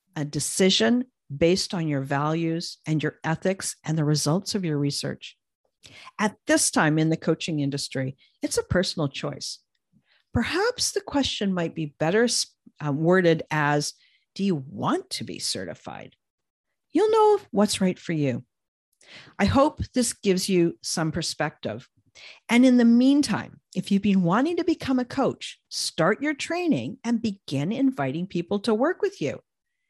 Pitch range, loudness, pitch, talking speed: 155-250 Hz, -24 LUFS, 190 Hz, 155 wpm